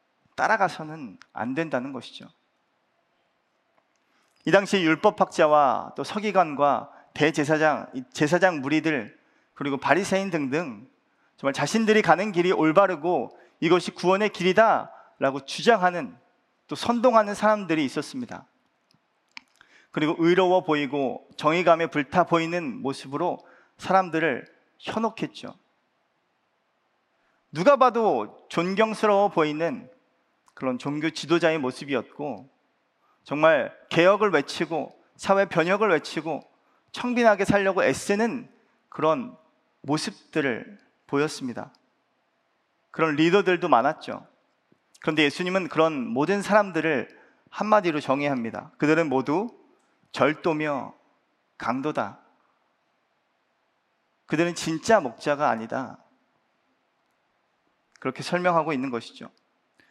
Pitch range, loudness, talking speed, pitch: 155-205 Hz, -24 LUFS, 245 characters per minute, 170 Hz